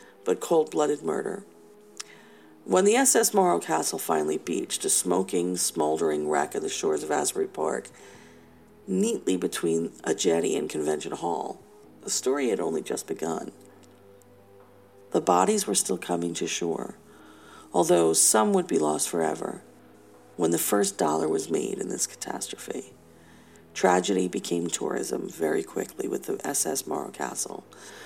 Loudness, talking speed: -26 LUFS, 140 wpm